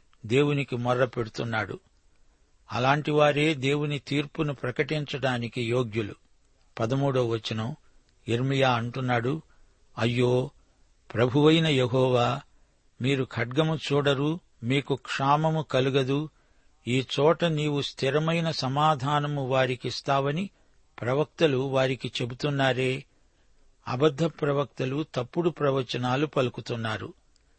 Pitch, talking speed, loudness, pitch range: 135 Hz, 75 wpm, -27 LUFS, 125-145 Hz